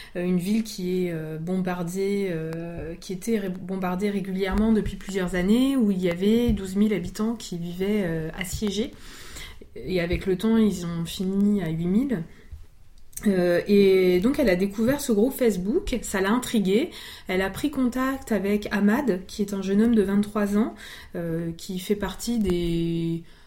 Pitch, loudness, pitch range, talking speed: 195 Hz, -25 LUFS, 180-215 Hz, 155 wpm